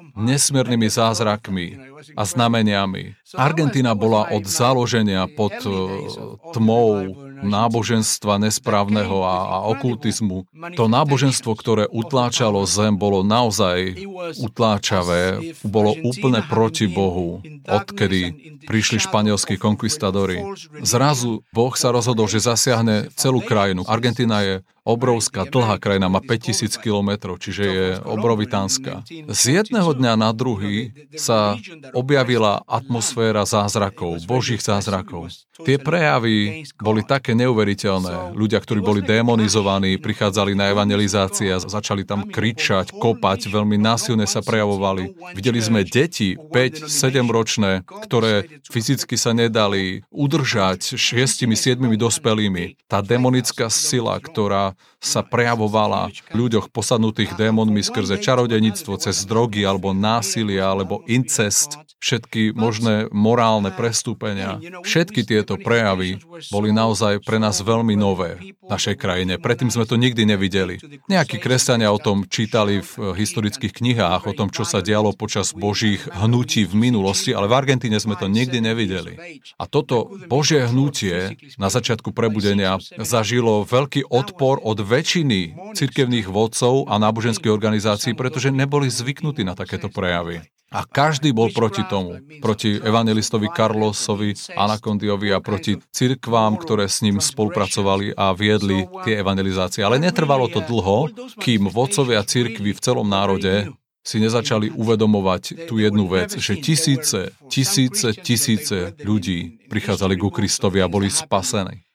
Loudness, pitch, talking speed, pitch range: -19 LUFS, 110 Hz, 120 wpm, 100-120 Hz